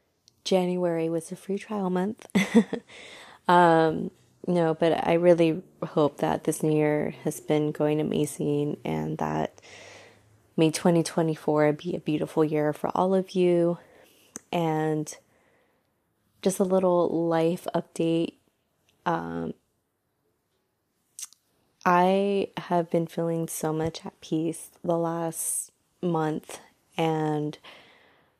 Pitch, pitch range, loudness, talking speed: 165 Hz, 155-180 Hz, -26 LUFS, 110 wpm